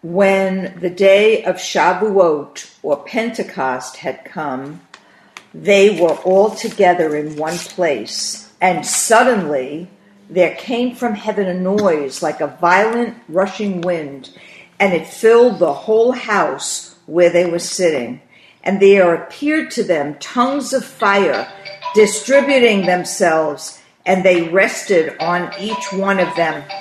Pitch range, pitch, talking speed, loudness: 175-220 Hz, 195 Hz, 130 wpm, -16 LUFS